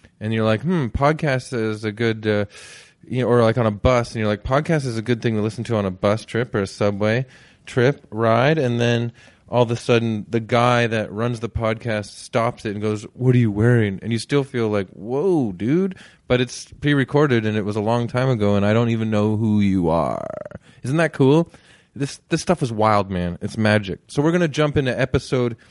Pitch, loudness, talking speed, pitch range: 115 Hz, -20 LUFS, 230 wpm, 105-125 Hz